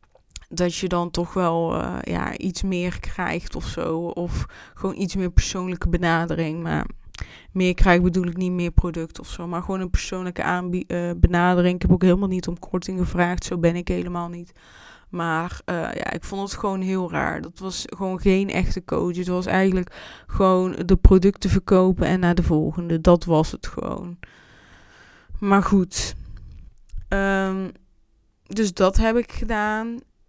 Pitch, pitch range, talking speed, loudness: 180 Hz, 170-190 Hz, 170 wpm, -22 LUFS